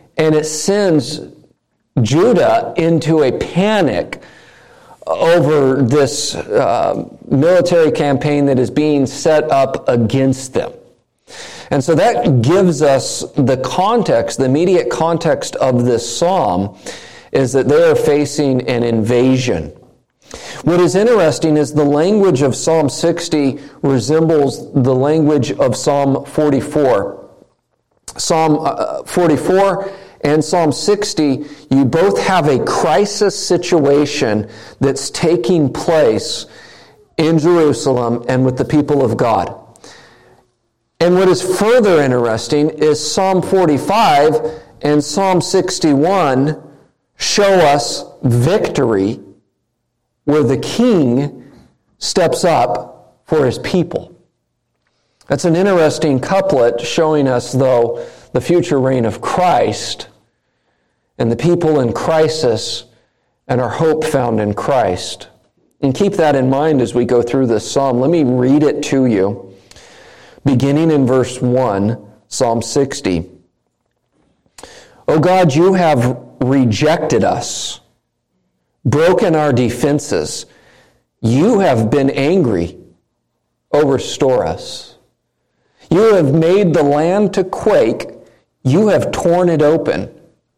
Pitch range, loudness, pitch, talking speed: 125-165 Hz, -14 LUFS, 145 Hz, 115 wpm